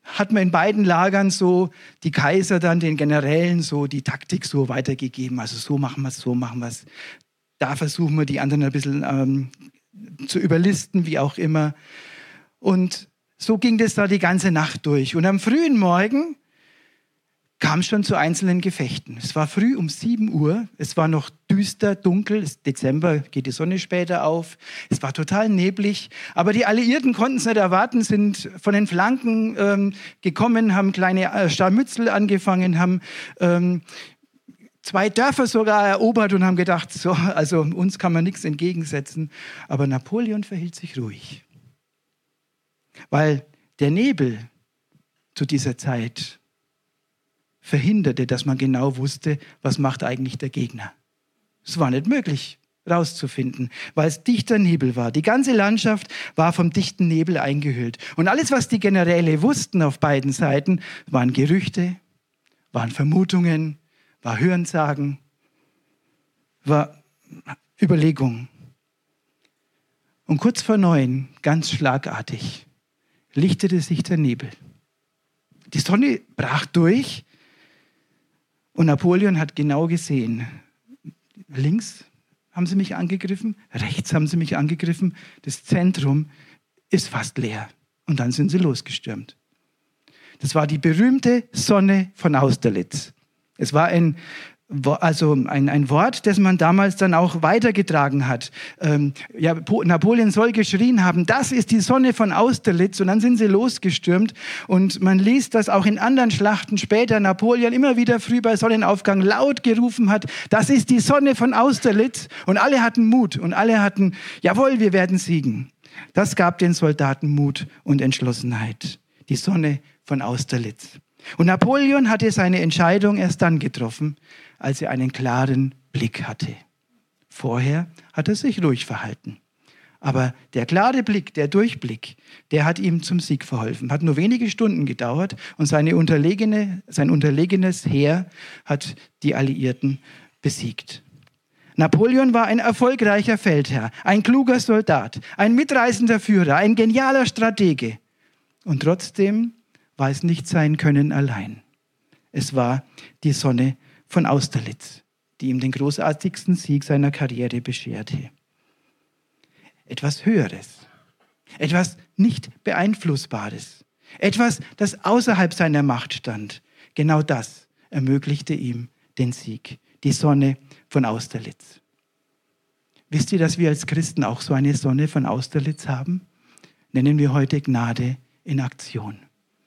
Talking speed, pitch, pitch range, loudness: 140 wpm, 165 Hz, 140-200 Hz, -20 LUFS